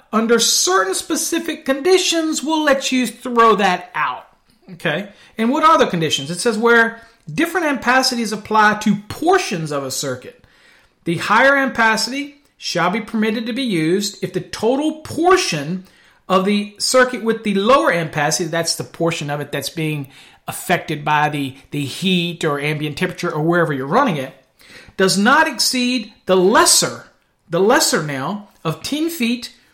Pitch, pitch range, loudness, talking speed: 215 Hz, 165-255 Hz, -17 LUFS, 155 wpm